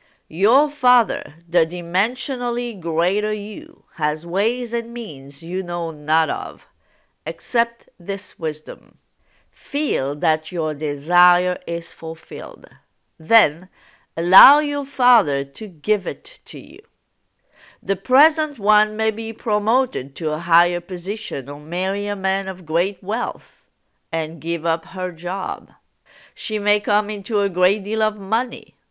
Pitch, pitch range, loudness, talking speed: 190 Hz, 165-220 Hz, -20 LUFS, 130 wpm